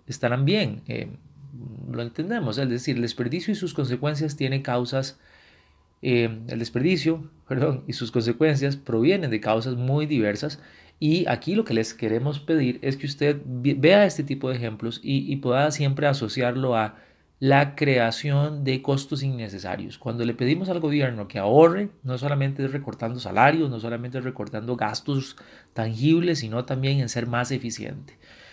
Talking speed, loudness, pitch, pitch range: 155 wpm, -24 LUFS, 135 Hz, 120-145 Hz